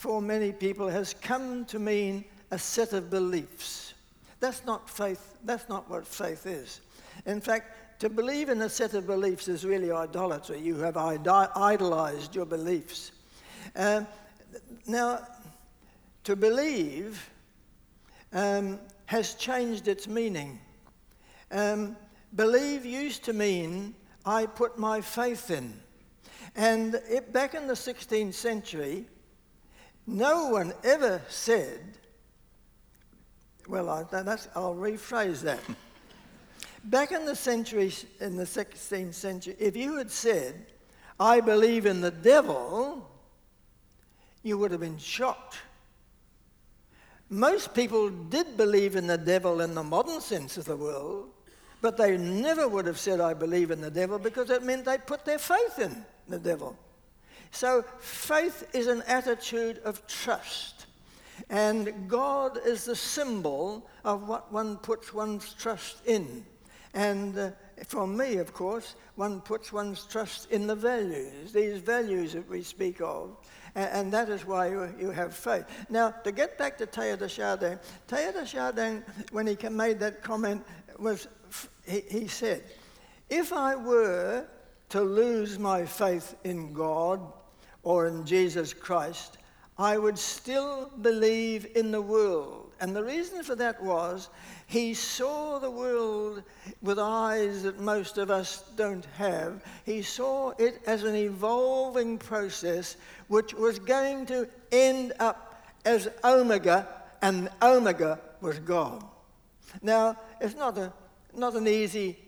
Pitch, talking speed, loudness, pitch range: 215 Hz, 140 wpm, -29 LUFS, 190-235 Hz